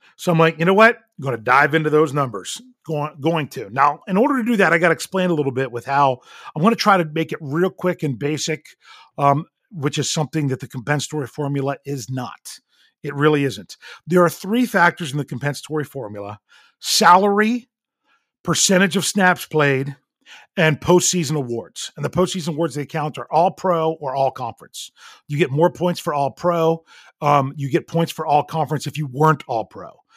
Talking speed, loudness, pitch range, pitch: 195 wpm, -19 LUFS, 140-175 Hz, 155 Hz